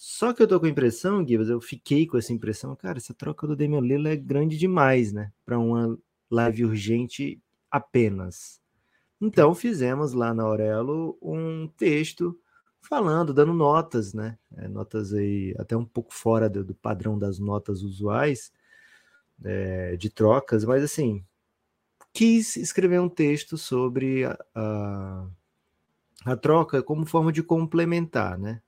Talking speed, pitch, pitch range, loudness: 140 wpm, 125 Hz, 110-160 Hz, -25 LUFS